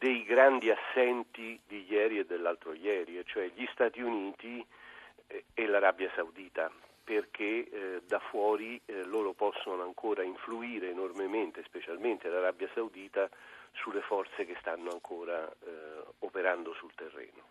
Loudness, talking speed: -34 LUFS, 115 wpm